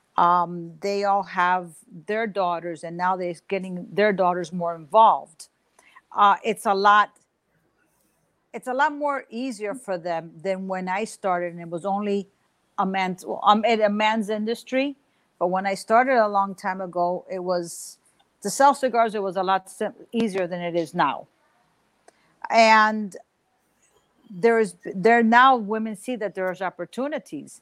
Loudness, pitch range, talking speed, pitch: -23 LUFS, 180-225 Hz, 160 wpm, 200 Hz